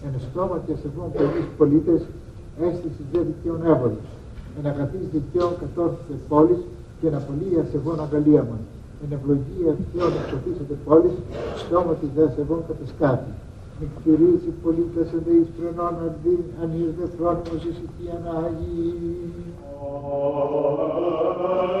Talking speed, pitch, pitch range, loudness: 125 wpm, 160 Hz, 145-170 Hz, -23 LUFS